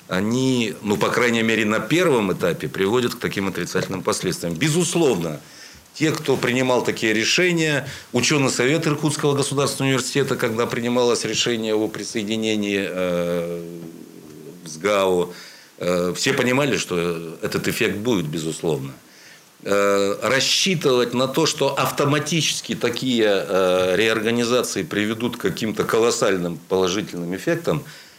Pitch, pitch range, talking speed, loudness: 115 Hz, 95-135 Hz, 110 wpm, -21 LUFS